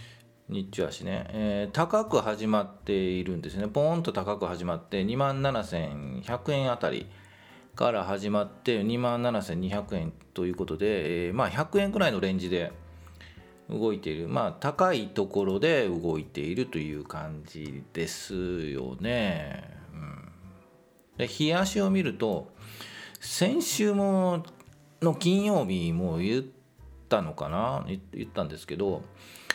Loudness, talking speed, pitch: -29 LUFS, 240 characters per minute, 105 Hz